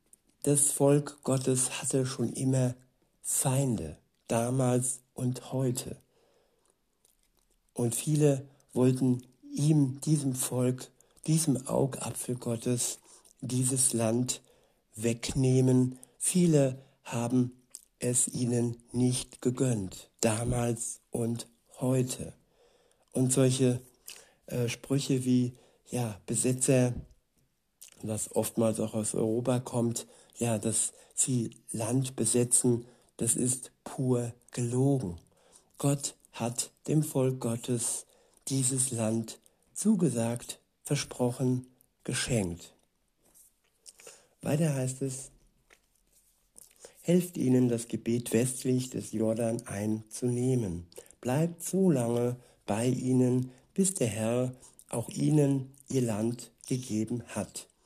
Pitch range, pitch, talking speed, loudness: 115-135 Hz, 125 Hz, 90 wpm, -30 LUFS